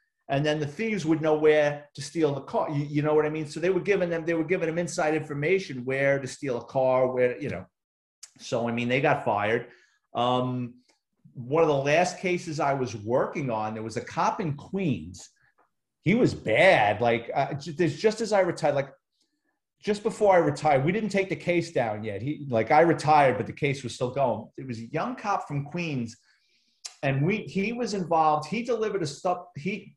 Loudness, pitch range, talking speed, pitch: -26 LUFS, 135-180 Hz, 215 wpm, 155 Hz